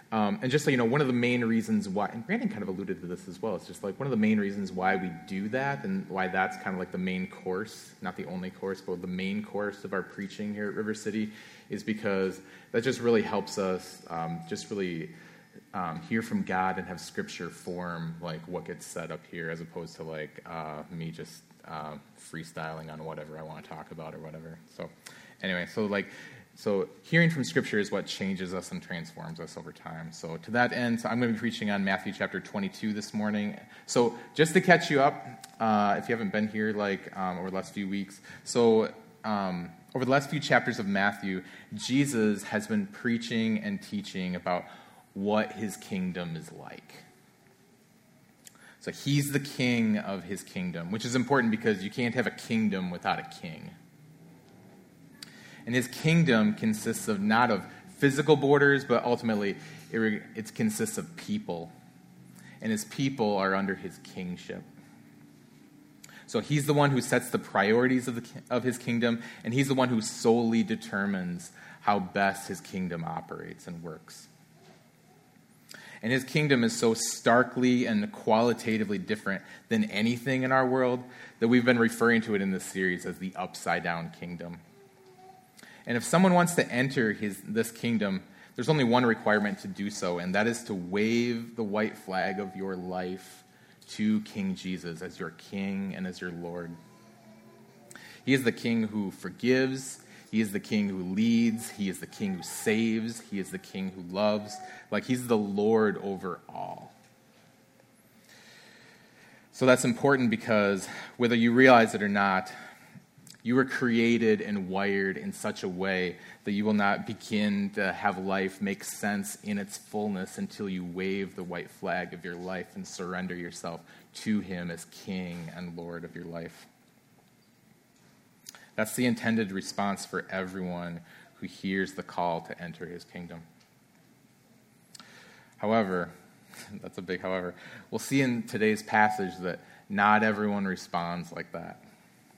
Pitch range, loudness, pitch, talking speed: 95-130 Hz, -29 LUFS, 110 Hz, 175 wpm